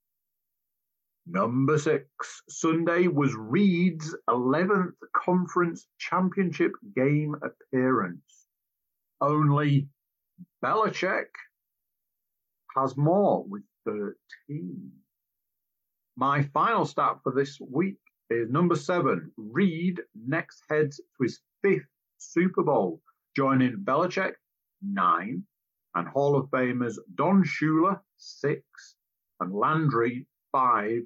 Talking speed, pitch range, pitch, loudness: 90 wpm, 135-180 Hz, 155 Hz, -27 LUFS